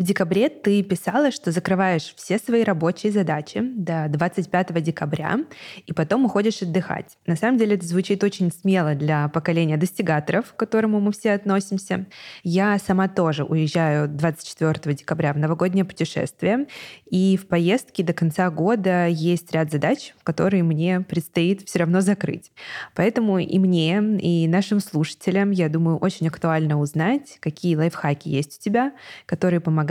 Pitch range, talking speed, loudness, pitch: 165-200 Hz, 150 wpm, -22 LUFS, 180 Hz